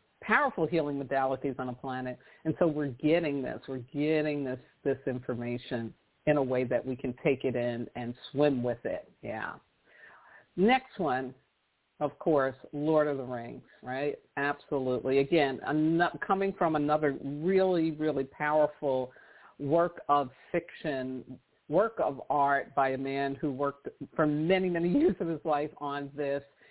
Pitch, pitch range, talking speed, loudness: 145 Hz, 130-155 Hz, 150 wpm, -31 LUFS